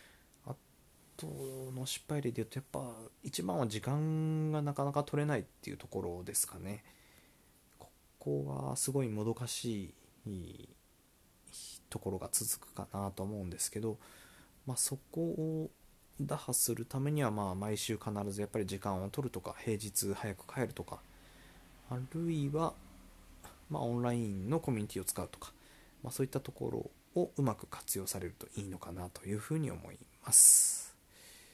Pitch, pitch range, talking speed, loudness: 110 Hz, 100-135 Hz, 310 characters per minute, -35 LUFS